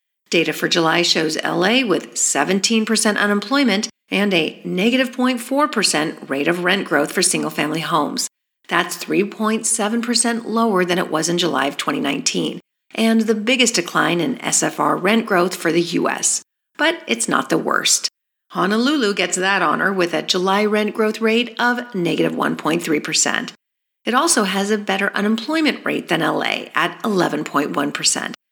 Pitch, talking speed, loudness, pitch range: 205 Hz, 145 wpm, -18 LUFS, 180-230 Hz